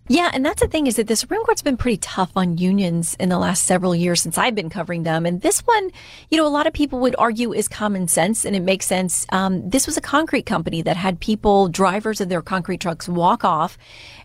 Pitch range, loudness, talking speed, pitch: 175-255 Hz, -19 LUFS, 250 wpm, 195 Hz